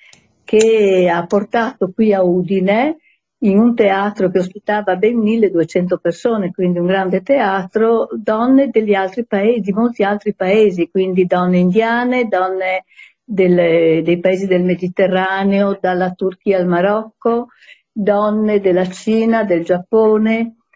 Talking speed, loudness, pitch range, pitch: 120 wpm, -15 LUFS, 185-220 Hz, 200 Hz